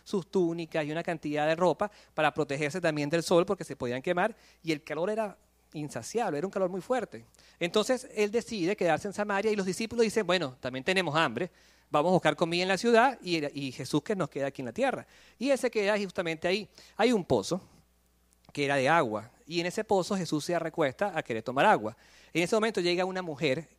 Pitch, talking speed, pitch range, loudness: 175 Hz, 215 wpm, 150-200 Hz, -29 LUFS